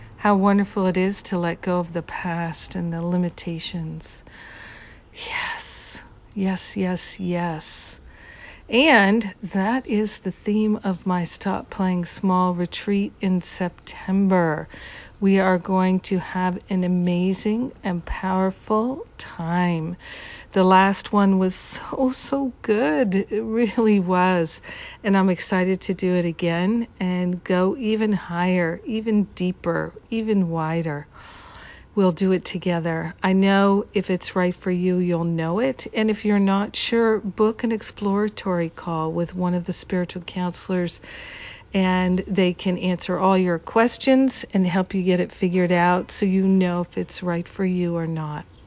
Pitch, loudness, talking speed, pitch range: 185 Hz, -22 LUFS, 145 wpm, 180-205 Hz